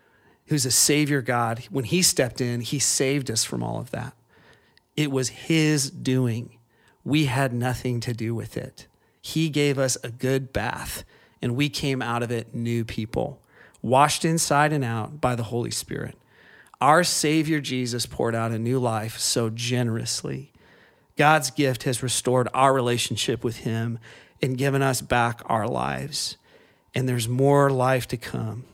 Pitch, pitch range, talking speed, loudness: 125 Hz, 115-140 Hz, 165 wpm, -24 LUFS